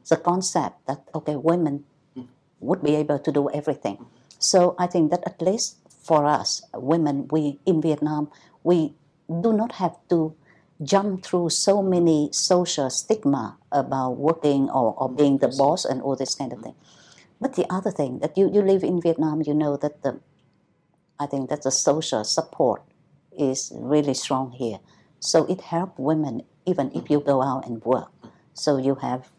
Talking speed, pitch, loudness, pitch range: 175 wpm, 150 Hz, -23 LUFS, 140-175 Hz